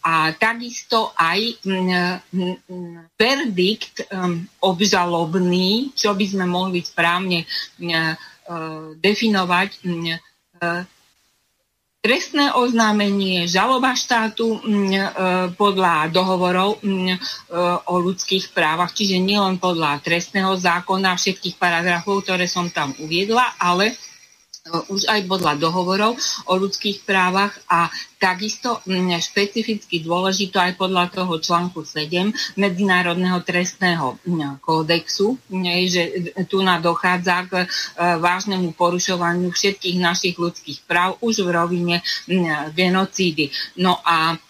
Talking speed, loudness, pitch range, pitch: 105 wpm, -19 LUFS, 175-200 Hz, 185 Hz